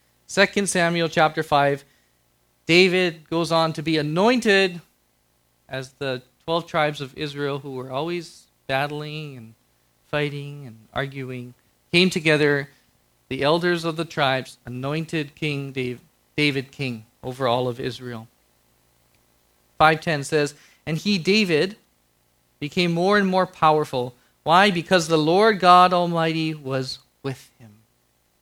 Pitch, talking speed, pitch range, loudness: 145 Hz, 120 wpm, 120-165 Hz, -21 LUFS